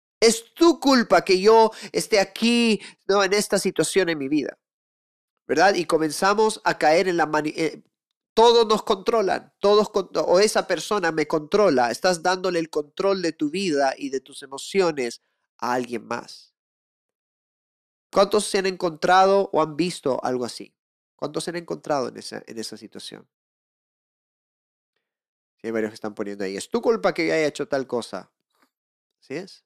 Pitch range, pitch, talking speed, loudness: 140-205 Hz, 180 Hz, 165 wpm, -22 LUFS